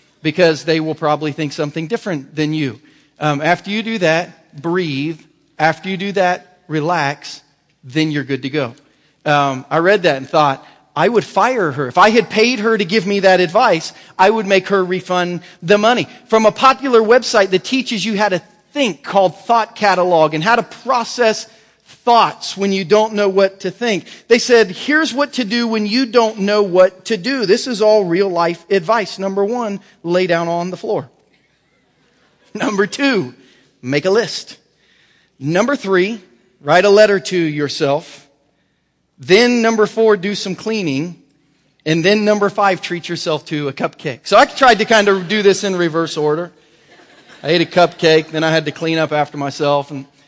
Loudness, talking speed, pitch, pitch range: -15 LUFS, 185 wpm, 185 Hz, 155-215 Hz